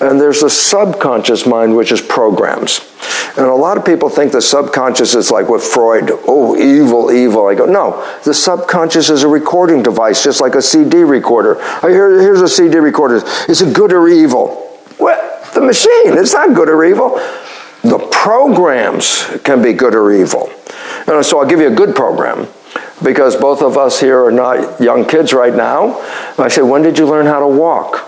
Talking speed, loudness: 195 wpm, -9 LUFS